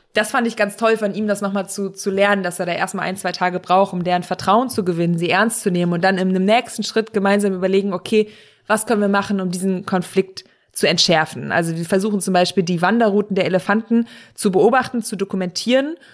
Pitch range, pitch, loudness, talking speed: 185-215 Hz, 195 Hz, -18 LUFS, 220 wpm